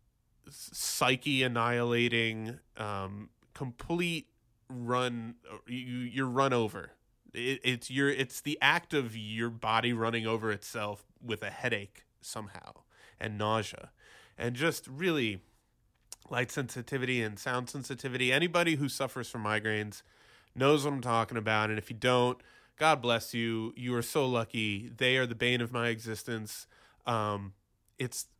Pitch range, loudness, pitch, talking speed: 110-130 Hz, -32 LUFS, 120 Hz, 135 wpm